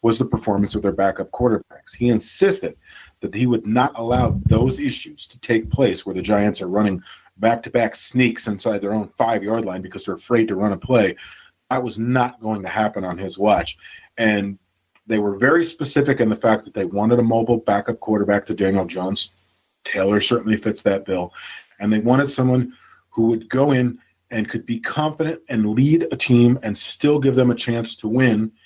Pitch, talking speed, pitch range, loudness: 115 Hz, 205 wpm, 100-125 Hz, -20 LUFS